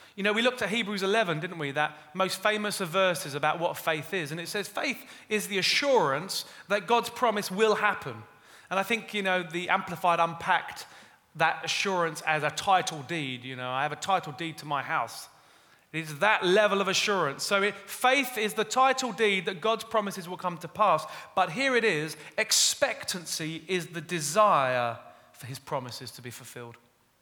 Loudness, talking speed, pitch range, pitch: -27 LUFS, 190 wpm, 155-210 Hz, 185 Hz